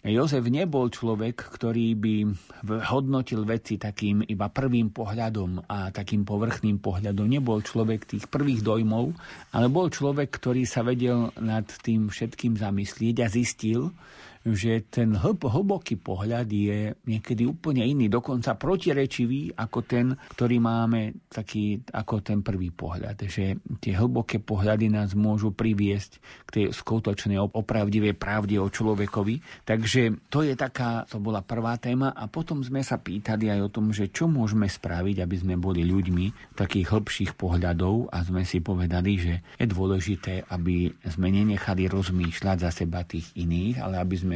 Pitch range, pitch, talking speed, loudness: 100-120 Hz, 110 Hz, 150 wpm, -27 LUFS